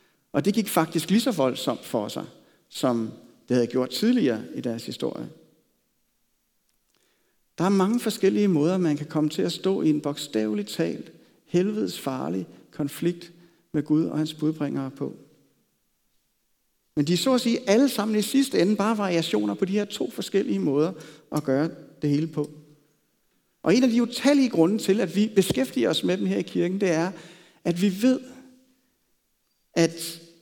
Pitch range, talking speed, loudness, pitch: 150-205 Hz, 170 wpm, -25 LUFS, 170 Hz